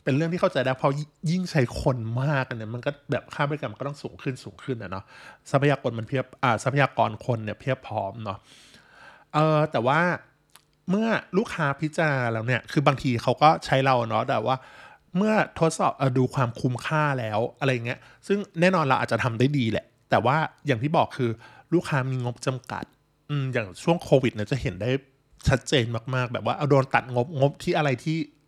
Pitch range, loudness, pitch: 125-150 Hz, -25 LUFS, 135 Hz